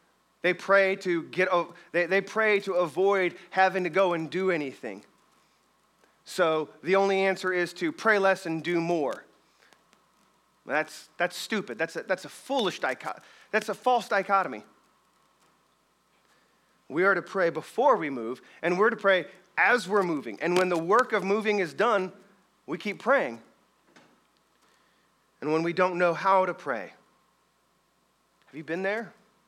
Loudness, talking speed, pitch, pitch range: -27 LUFS, 155 wpm, 190 Hz, 175-200 Hz